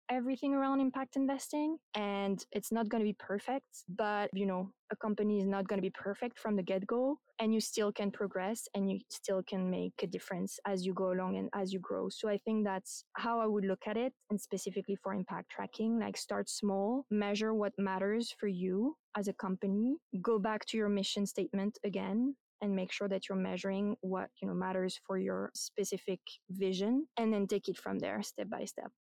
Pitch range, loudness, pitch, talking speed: 195-225 Hz, -36 LUFS, 205 Hz, 210 wpm